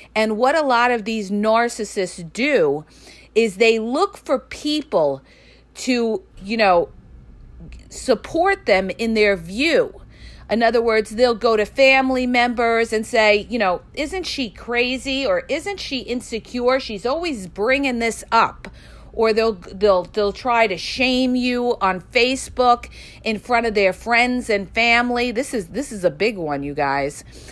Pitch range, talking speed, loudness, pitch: 205-255 Hz, 155 wpm, -19 LUFS, 230 Hz